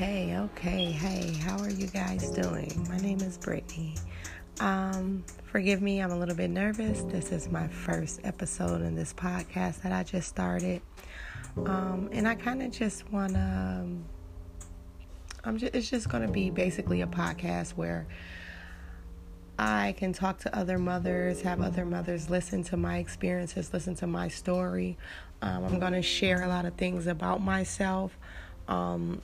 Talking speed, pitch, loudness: 155 wpm, 175 Hz, -32 LUFS